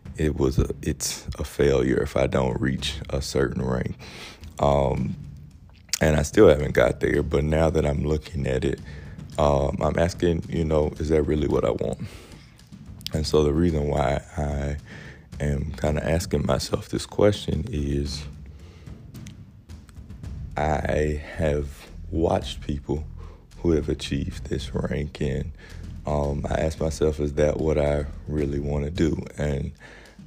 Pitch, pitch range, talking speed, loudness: 75 Hz, 70-80 Hz, 150 wpm, -25 LUFS